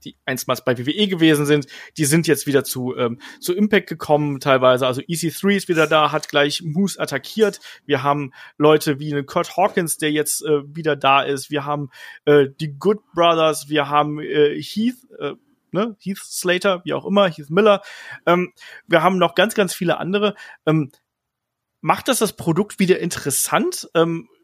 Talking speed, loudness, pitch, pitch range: 180 wpm, -19 LUFS, 155 Hz, 145-190 Hz